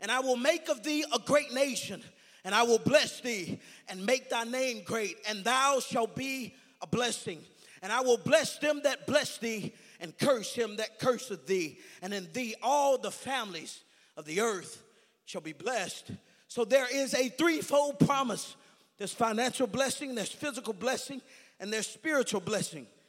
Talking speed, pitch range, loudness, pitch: 175 wpm, 215-270 Hz, -31 LUFS, 245 Hz